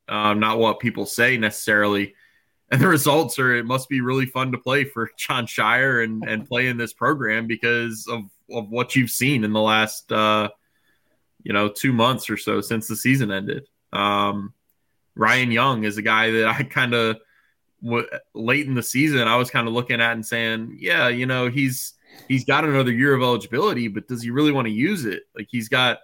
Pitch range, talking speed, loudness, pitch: 110-125 Hz, 205 wpm, -21 LUFS, 115 Hz